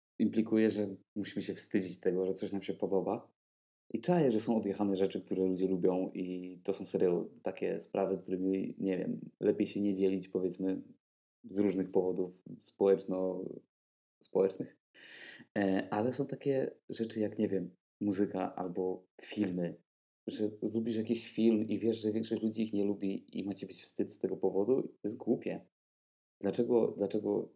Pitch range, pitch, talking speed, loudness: 95-110 Hz, 95 Hz, 160 wpm, -35 LUFS